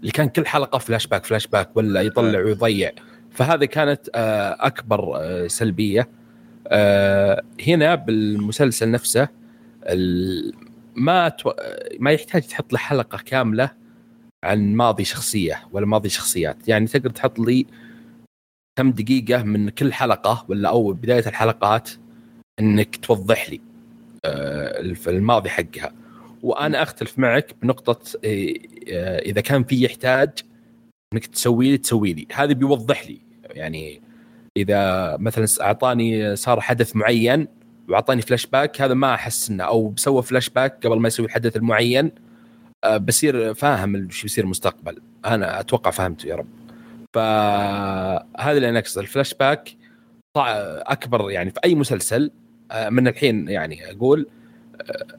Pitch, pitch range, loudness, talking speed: 115 Hz, 105-140 Hz, -20 LUFS, 120 wpm